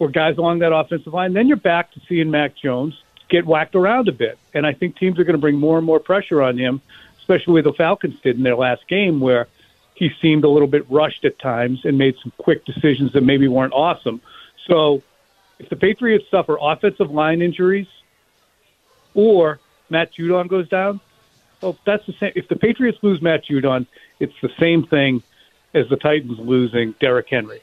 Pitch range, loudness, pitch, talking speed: 135-180 Hz, -18 LUFS, 155 Hz, 200 wpm